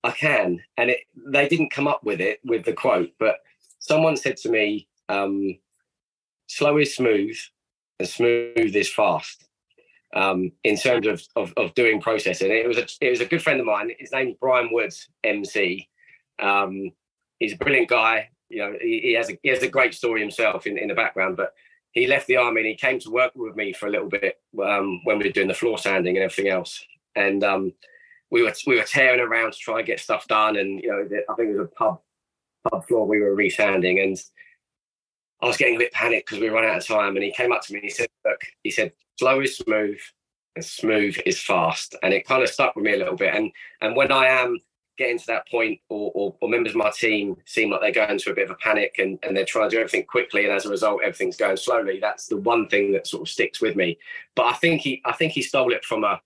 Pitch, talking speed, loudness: 125 Hz, 245 wpm, -22 LUFS